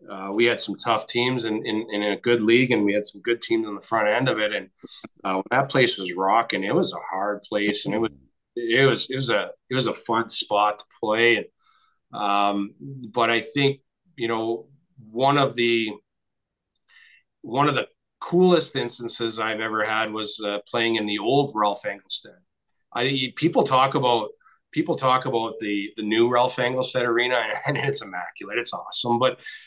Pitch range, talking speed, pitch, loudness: 105-130 Hz, 190 wpm, 115 Hz, -23 LUFS